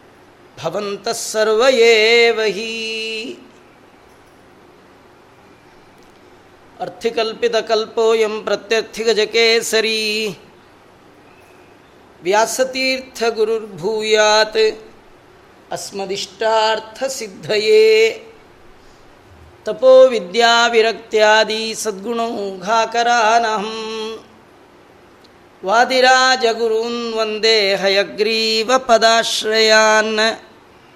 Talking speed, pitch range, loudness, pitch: 45 wpm, 215-230 Hz, -15 LUFS, 220 Hz